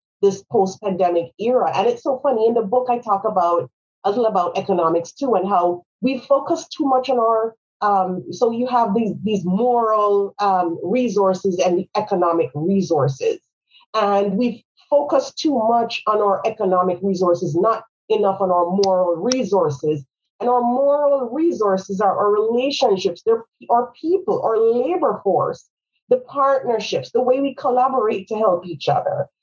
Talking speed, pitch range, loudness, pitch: 155 wpm, 190-250 Hz, -19 LUFS, 220 Hz